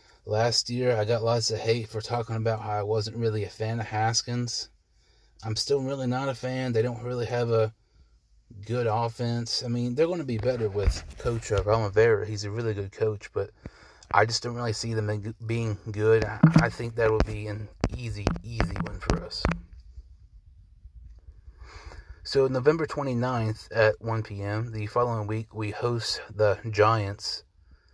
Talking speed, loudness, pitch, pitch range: 170 wpm, -27 LUFS, 110 Hz, 105-120 Hz